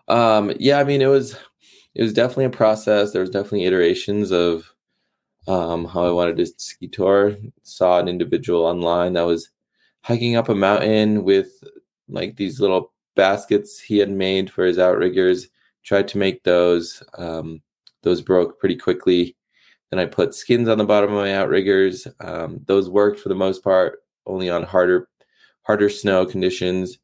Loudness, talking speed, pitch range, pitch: -19 LUFS, 170 wpm, 90-110 Hz, 95 Hz